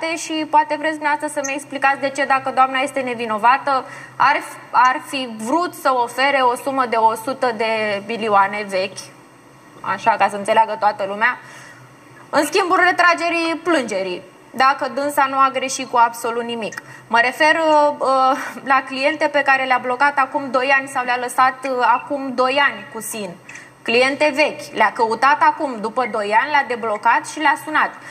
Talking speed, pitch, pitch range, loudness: 160 wpm, 265 Hz, 235-290 Hz, -18 LUFS